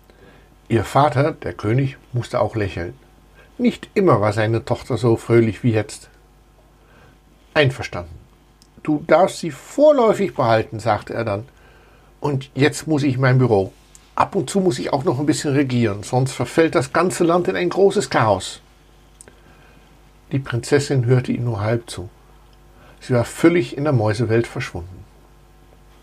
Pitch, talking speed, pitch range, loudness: 125 Hz, 150 wpm, 115-150 Hz, -19 LUFS